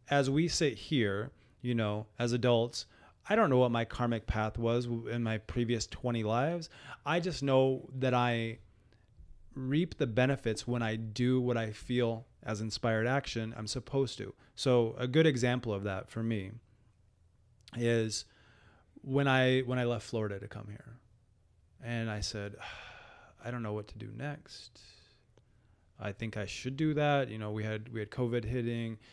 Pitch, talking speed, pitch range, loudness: 115 Hz, 170 wpm, 105-125 Hz, -33 LUFS